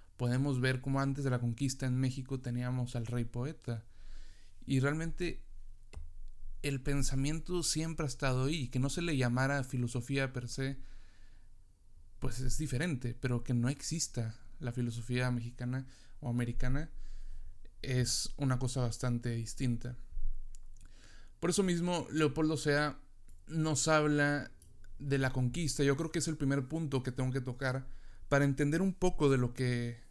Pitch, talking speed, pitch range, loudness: 130 Hz, 150 wpm, 120-140 Hz, -35 LUFS